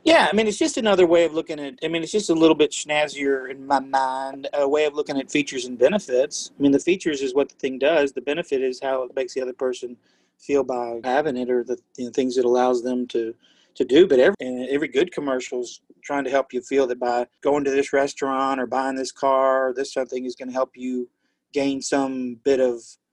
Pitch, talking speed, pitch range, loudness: 135 Hz, 245 wpm, 125-145 Hz, -22 LUFS